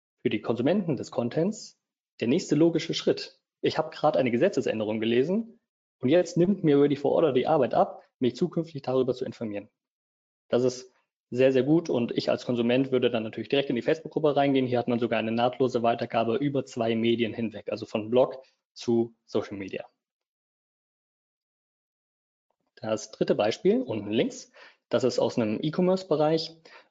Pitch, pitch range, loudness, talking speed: 125 Hz, 115-150 Hz, -26 LUFS, 165 wpm